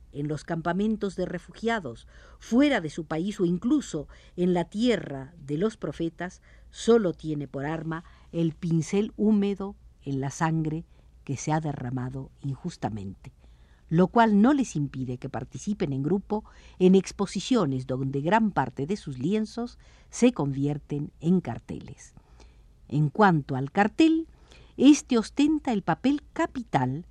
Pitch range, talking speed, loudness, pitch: 140-210 Hz, 135 wpm, -27 LUFS, 170 Hz